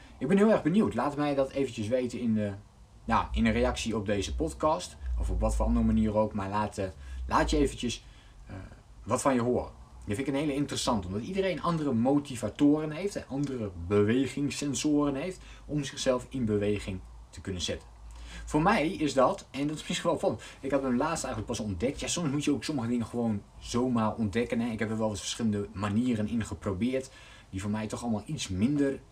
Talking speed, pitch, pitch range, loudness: 205 wpm, 115 Hz, 105-140 Hz, -30 LUFS